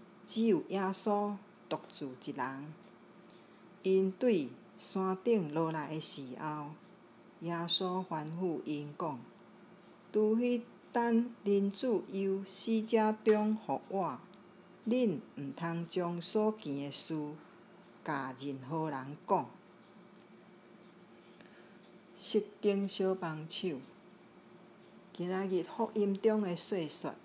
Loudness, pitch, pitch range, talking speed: -35 LUFS, 190 Hz, 160-205 Hz, 135 characters per minute